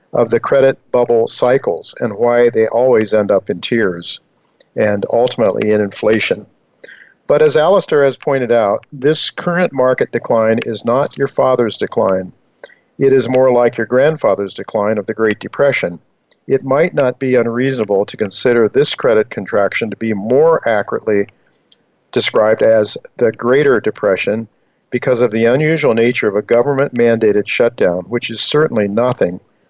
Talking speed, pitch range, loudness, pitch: 155 wpm, 115-140 Hz, -14 LUFS, 125 Hz